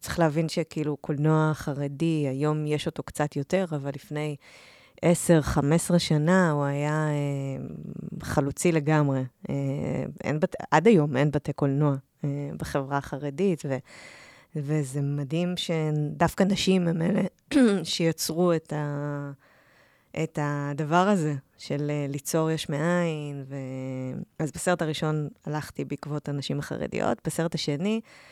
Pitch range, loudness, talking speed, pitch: 145-170 Hz, -27 LUFS, 120 wpm, 150 Hz